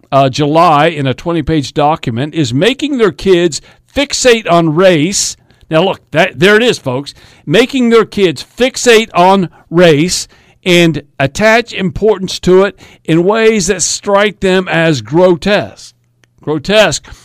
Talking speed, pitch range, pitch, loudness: 140 wpm, 150-205 Hz, 175 Hz, -10 LUFS